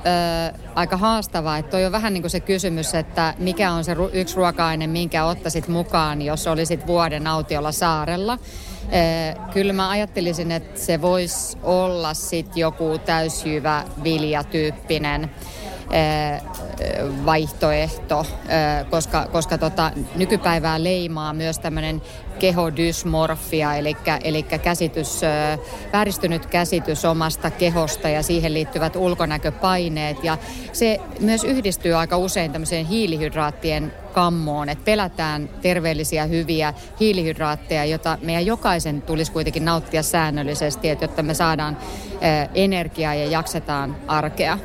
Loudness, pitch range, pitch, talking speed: -21 LUFS, 155-175 Hz, 165 Hz, 115 wpm